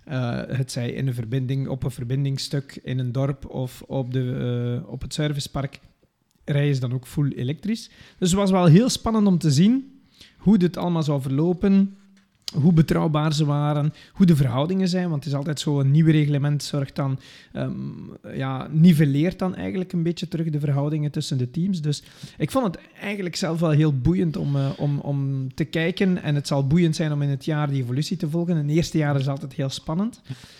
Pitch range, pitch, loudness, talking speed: 135-175 Hz, 150 Hz, -23 LUFS, 210 wpm